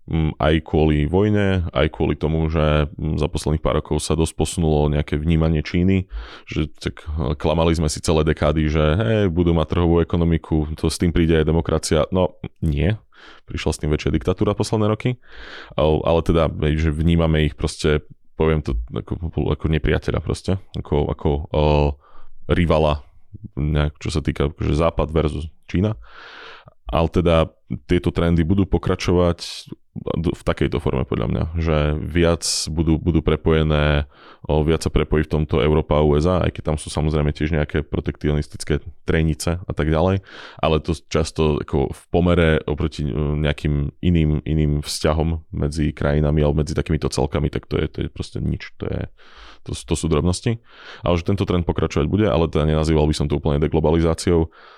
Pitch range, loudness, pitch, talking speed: 75-85 Hz, -20 LUFS, 80 Hz, 160 wpm